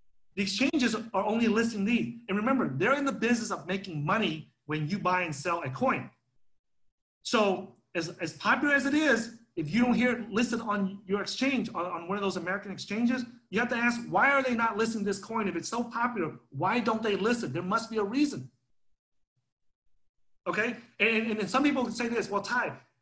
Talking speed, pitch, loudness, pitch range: 210 wpm, 210 Hz, -29 LUFS, 170-235 Hz